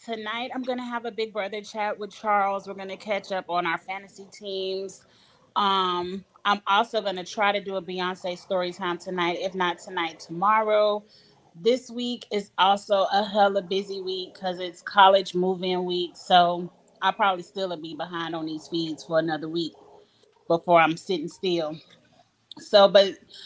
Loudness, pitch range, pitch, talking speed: -25 LUFS, 175-205 Hz, 190 Hz, 170 wpm